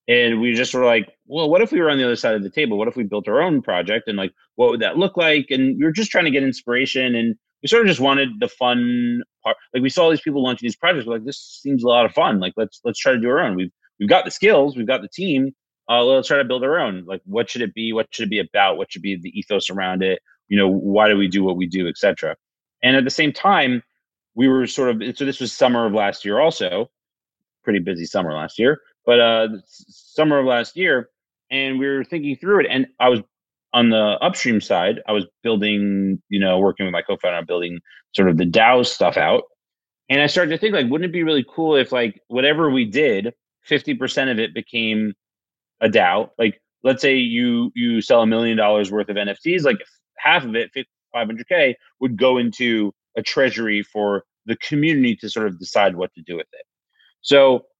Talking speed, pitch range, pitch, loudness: 240 wpm, 105-140 Hz, 120 Hz, -19 LUFS